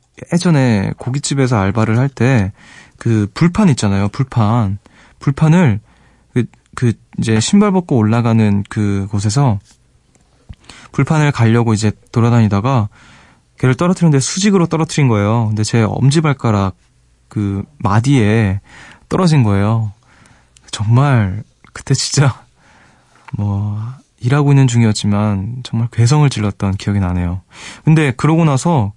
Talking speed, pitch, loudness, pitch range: 270 characters per minute, 115 Hz, -14 LUFS, 105-140 Hz